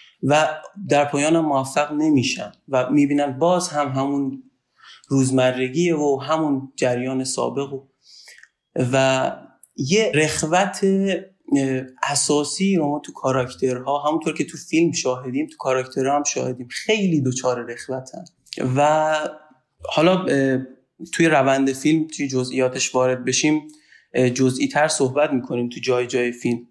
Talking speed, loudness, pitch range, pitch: 120 wpm, -21 LUFS, 130-155 Hz, 140 Hz